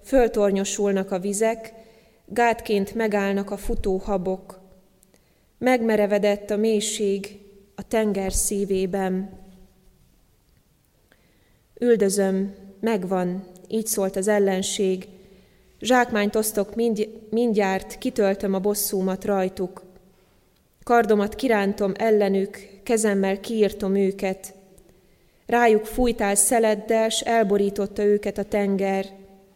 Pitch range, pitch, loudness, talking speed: 195-220 Hz, 200 Hz, -23 LUFS, 85 wpm